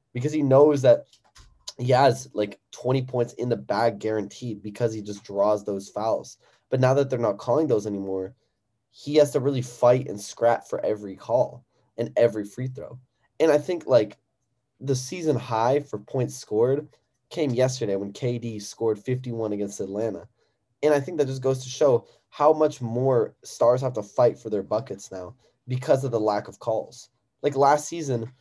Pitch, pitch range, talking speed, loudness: 125 Hz, 110-135 Hz, 185 wpm, -24 LUFS